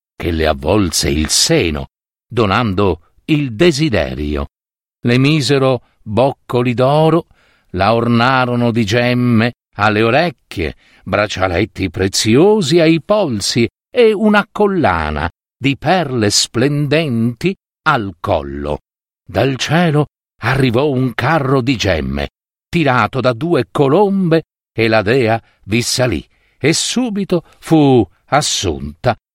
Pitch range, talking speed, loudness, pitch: 100-155 Hz, 100 wpm, -15 LUFS, 120 Hz